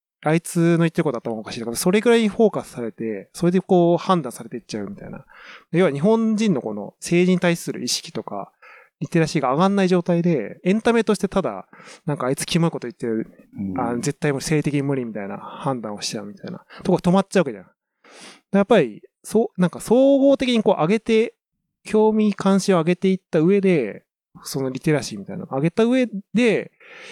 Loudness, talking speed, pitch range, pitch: -21 LUFS, 425 characters per minute, 145-205 Hz, 180 Hz